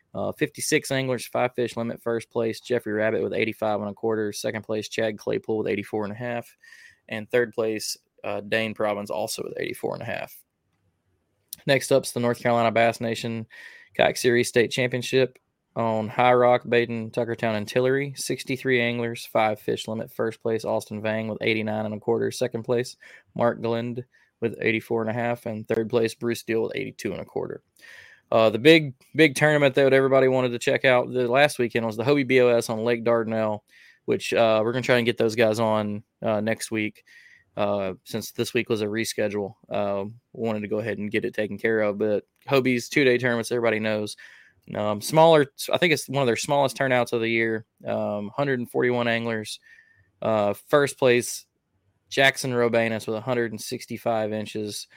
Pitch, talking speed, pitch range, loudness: 115 Hz, 185 wpm, 110-125 Hz, -24 LUFS